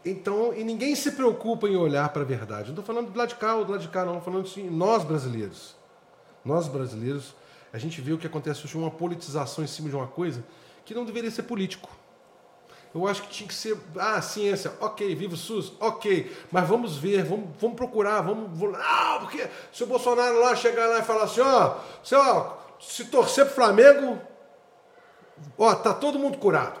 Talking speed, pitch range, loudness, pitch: 210 wpm, 165-235 Hz, -25 LUFS, 200 Hz